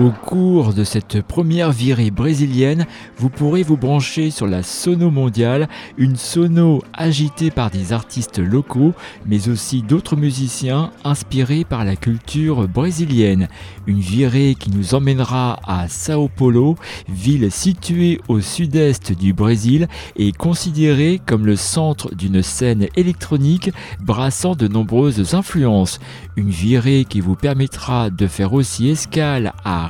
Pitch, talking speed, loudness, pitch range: 130 Hz, 135 wpm, -17 LUFS, 105-155 Hz